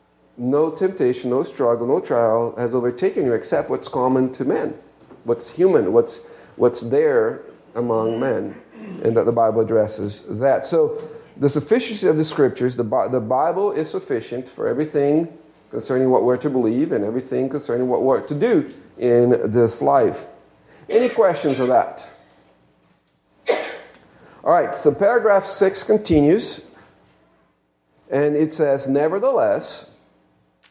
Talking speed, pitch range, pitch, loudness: 135 wpm, 115-180 Hz, 130 Hz, -19 LUFS